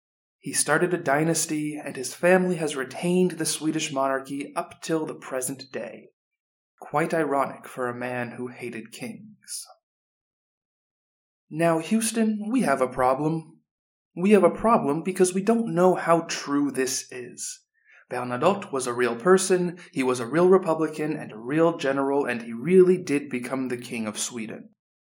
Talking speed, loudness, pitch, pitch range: 160 wpm, -24 LUFS, 155 Hz, 130-180 Hz